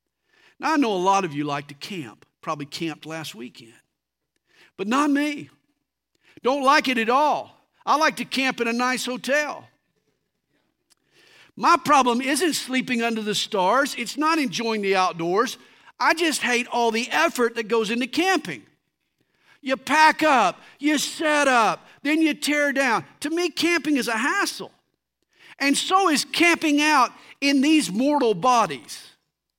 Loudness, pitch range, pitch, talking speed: -21 LUFS, 225-300 Hz, 265 Hz, 155 wpm